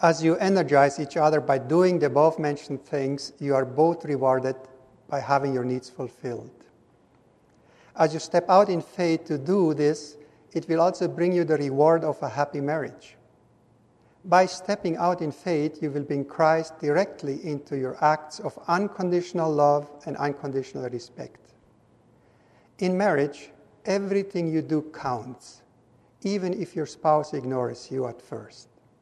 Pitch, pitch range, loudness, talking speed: 150 Hz, 140-170 Hz, -25 LUFS, 150 wpm